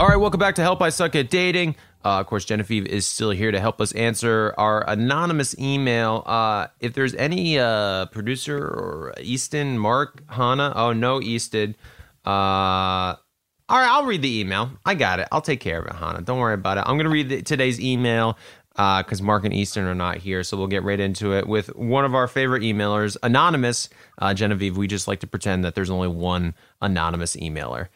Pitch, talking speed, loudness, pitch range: 110 Hz, 210 wpm, -22 LUFS, 95-130 Hz